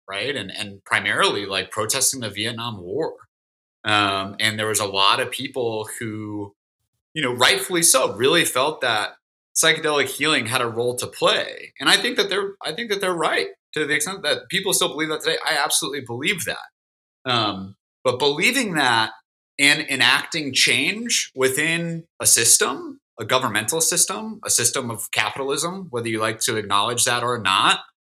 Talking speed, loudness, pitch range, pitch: 170 wpm, -20 LUFS, 110-170 Hz, 130 Hz